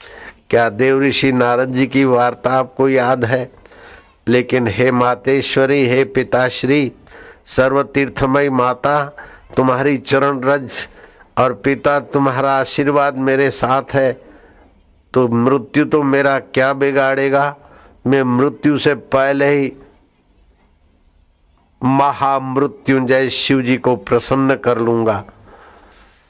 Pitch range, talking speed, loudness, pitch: 125-140 Hz, 105 wpm, -15 LUFS, 135 Hz